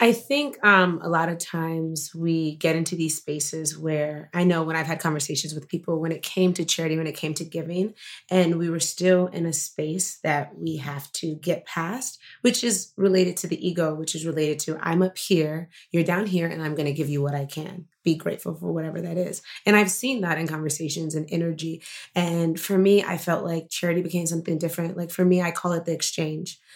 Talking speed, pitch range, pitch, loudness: 225 wpm, 160-180 Hz, 165 Hz, -25 LUFS